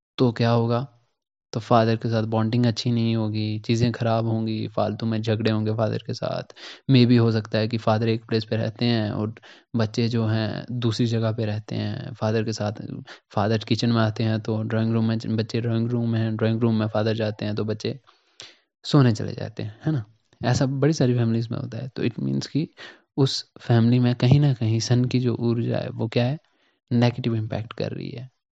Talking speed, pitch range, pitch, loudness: 215 wpm, 110-120 Hz, 115 Hz, -24 LUFS